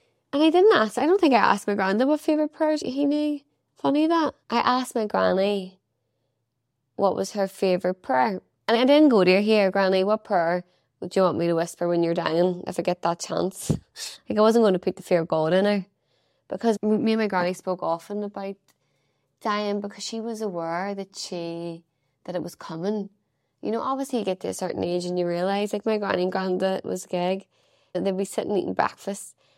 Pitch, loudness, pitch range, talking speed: 195 Hz, -24 LUFS, 180-220 Hz, 215 wpm